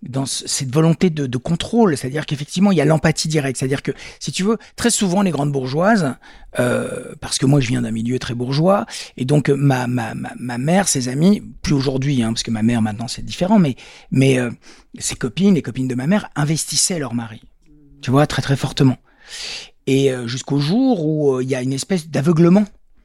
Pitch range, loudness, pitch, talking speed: 130-170 Hz, -18 LUFS, 140 Hz, 215 wpm